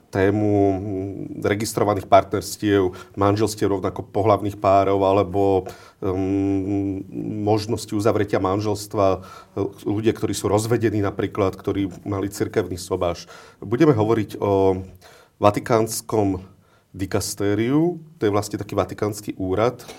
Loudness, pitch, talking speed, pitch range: -22 LUFS, 100 Hz, 95 wpm, 95-105 Hz